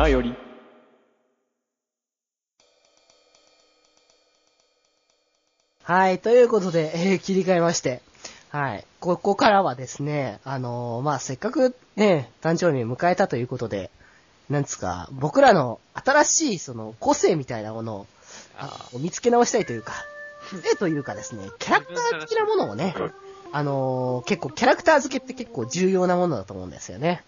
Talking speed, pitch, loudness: 300 characters per minute, 165 Hz, -23 LUFS